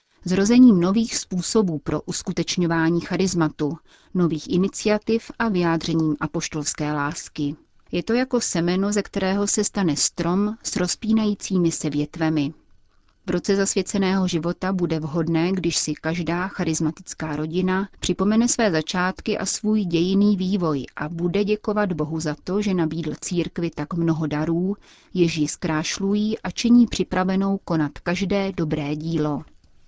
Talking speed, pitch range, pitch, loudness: 130 wpm, 160-200 Hz, 175 Hz, -22 LUFS